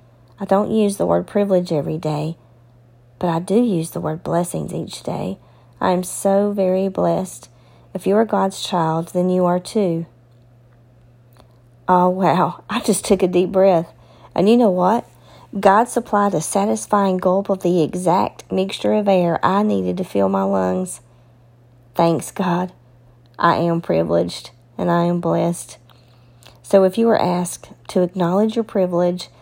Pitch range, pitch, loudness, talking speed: 120-195 Hz, 175 Hz, -19 LUFS, 160 wpm